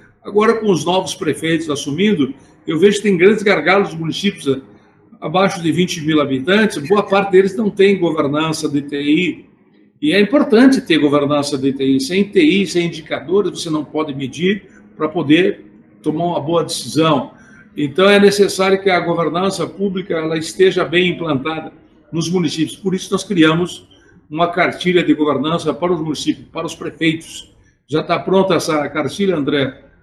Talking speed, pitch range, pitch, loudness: 160 wpm, 150-195 Hz, 165 Hz, -16 LUFS